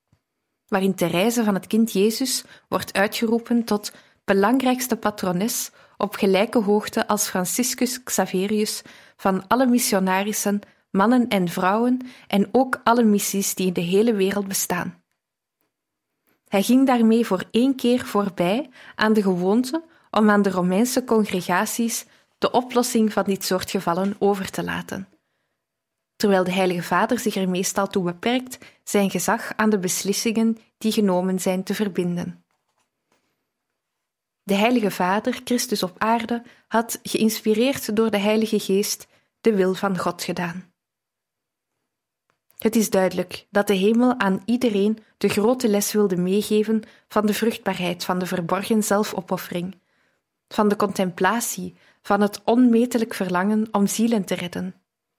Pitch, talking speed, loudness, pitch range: 205 Hz, 135 wpm, -22 LUFS, 190-230 Hz